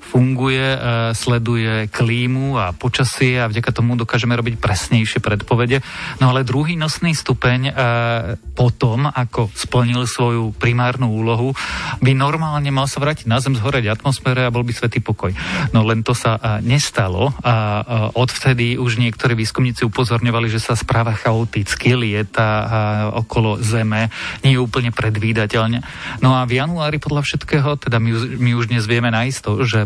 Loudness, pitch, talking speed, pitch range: -17 LUFS, 120 Hz, 145 wpm, 115-130 Hz